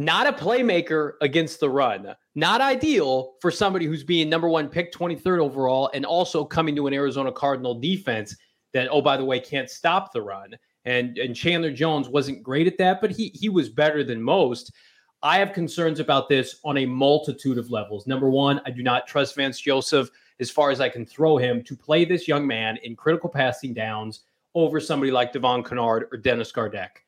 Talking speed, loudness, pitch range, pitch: 205 wpm, -23 LUFS, 130-165 Hz, 140 Hz